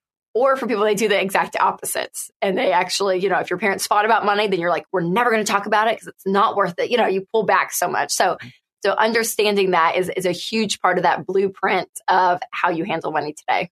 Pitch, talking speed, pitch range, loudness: 195 Hz, 260 wpm, 180-215 Hz, -19 LUFS